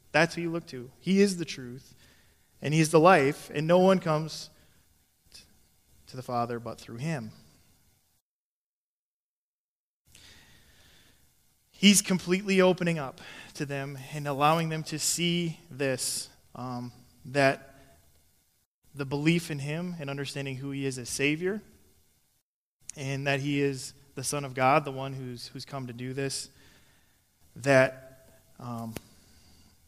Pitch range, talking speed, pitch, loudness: 120-155 Hz, 135 wpm, 135 Hz, -28 LUFS